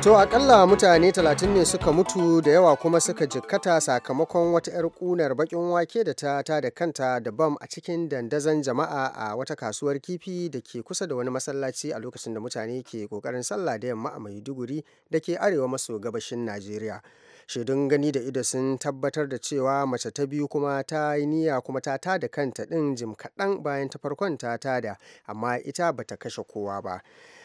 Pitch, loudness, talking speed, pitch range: 145 Hz, -25 LUFS, 155 wpm, 125-165 Hz